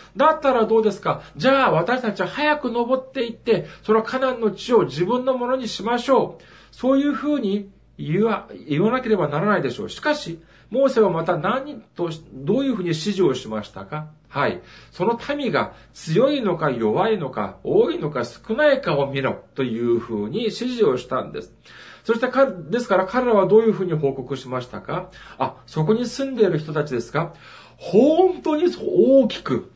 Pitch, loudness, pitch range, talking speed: 215 Hz, -21 LUFS, 160-255 Hz, 355 characters per minute